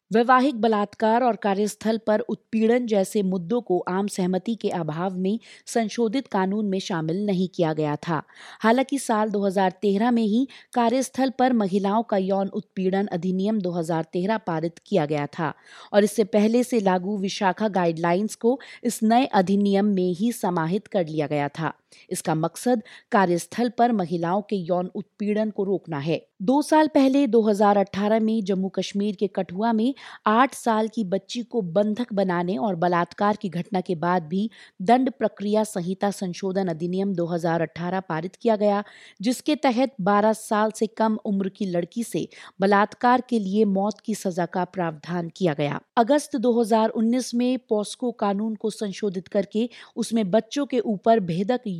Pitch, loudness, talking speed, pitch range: 205 Hz, -24 LUFS, 155 wpm, 185-230 Hz